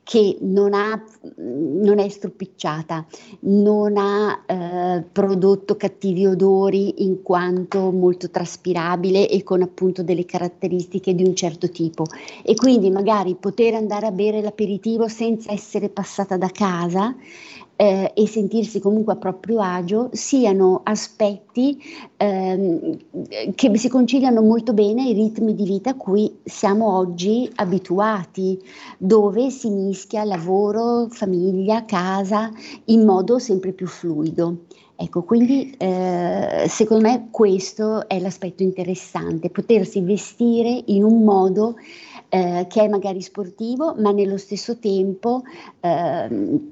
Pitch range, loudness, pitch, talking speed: 185-220 Hz, -20 LUFS, 200 Hz, 120 wpm